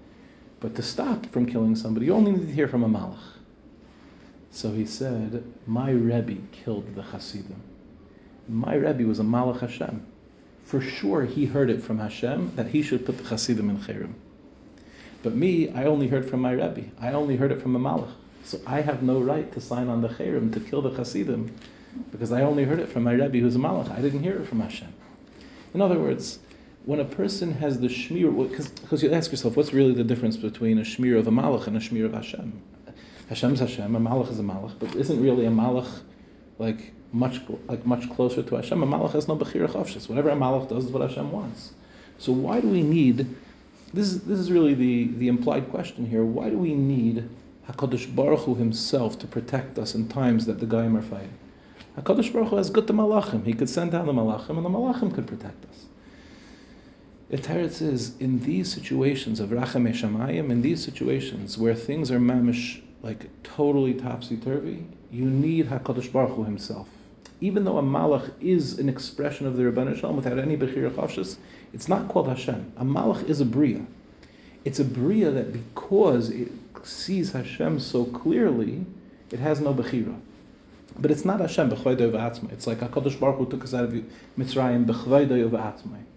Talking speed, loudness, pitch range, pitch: 195 wpm, -25 LUFS, 115-145 Hz, 125 Hz